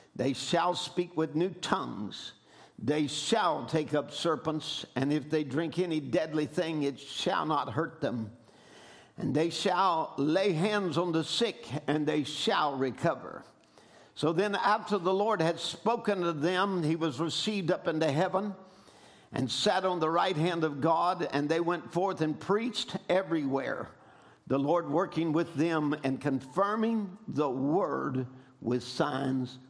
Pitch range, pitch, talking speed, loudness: 145-180 Hz, 160 Hz, 155 wpm, -30 LUFS